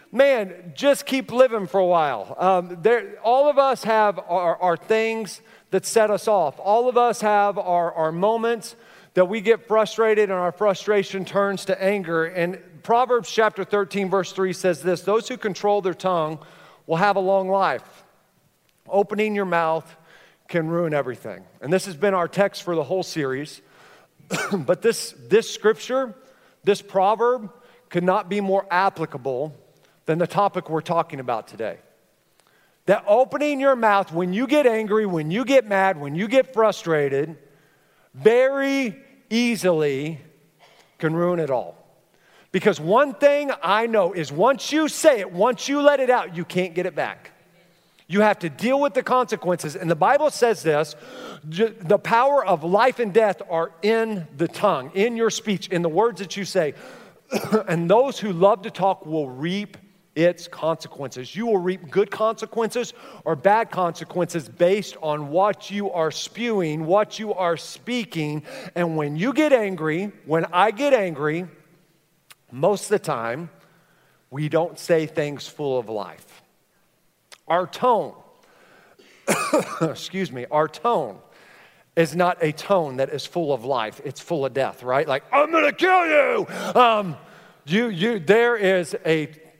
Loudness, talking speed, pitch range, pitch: -22 LUFS, 160 wpm, 165-220 Hz, 190 Hz